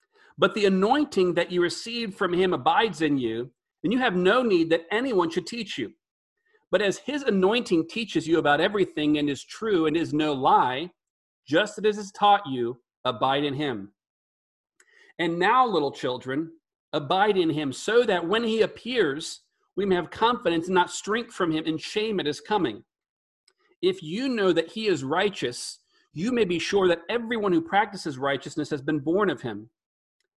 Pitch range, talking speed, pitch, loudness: 155-225 Hz, 180 wpm, 180 Hz, -25 LUFS